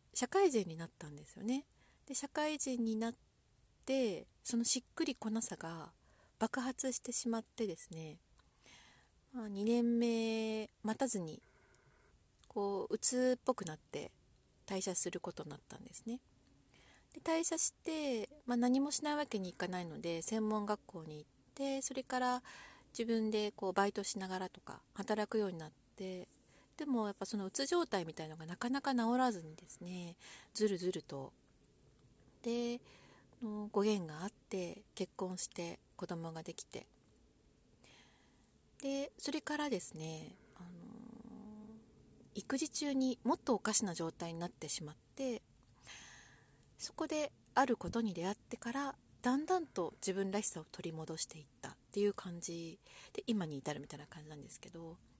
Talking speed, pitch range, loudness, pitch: 285 characters per minute, 175-255 Hz, -38 LUFS, 215 Hz